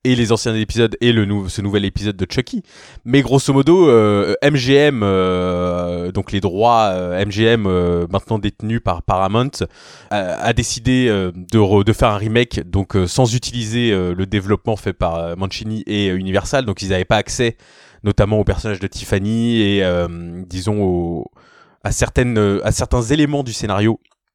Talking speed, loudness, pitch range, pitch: 180 wpm, -17 LUFS, 95-120 Hz, 105 Hz